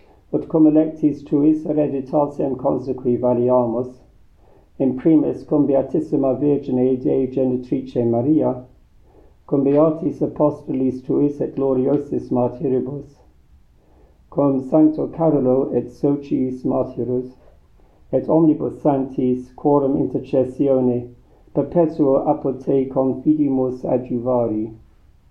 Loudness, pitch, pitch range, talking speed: -19 LUFS, 130 Hz, 125-145 Hz, 90 wpm